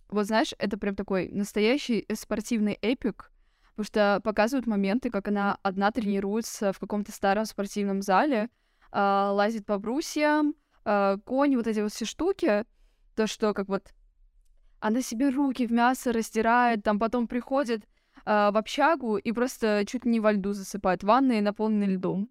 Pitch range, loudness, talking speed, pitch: 200-240 Hz, -27 LUFS, 150 wpm, 215 Hz